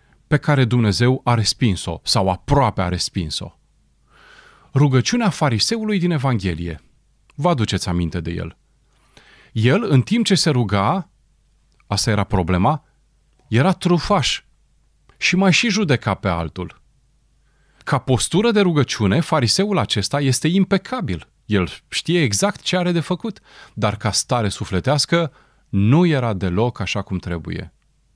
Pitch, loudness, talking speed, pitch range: 125 Hz, -19 LUFS, 130 wpm, 100-170 Hz